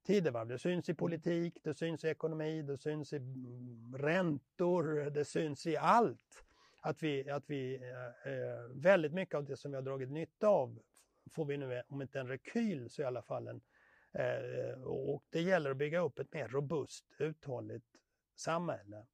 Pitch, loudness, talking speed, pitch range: 145 Hz, -38 LUFS, 170 wpm, 130-160 Hz